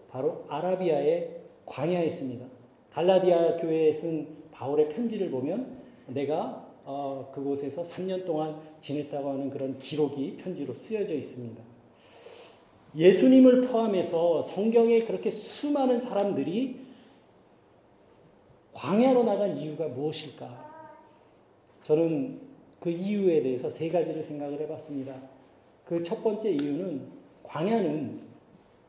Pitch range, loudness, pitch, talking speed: 140-220 Hz, -28 LUFS, 165 Hz, 260 characters per minute